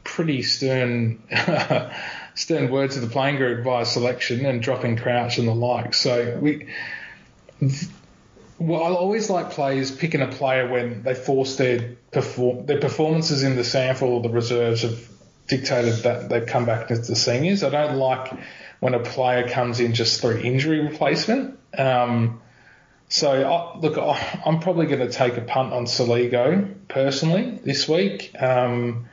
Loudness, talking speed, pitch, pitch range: -22 LUFS, 160 wpm, 130 Hz, 120-145 Hz